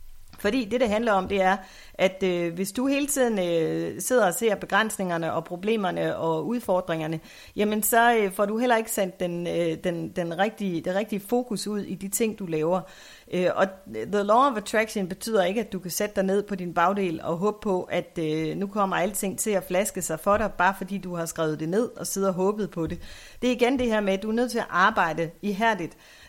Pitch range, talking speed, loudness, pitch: 175-215 Hz, 235 wpm, -25 LUFS, 195 Hz